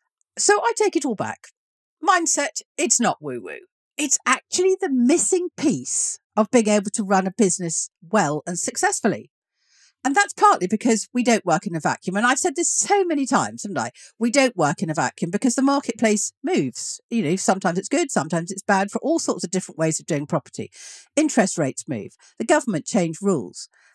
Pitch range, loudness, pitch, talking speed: 185-295 Hz, -21 LUFS, 220 Hz, 195 wpm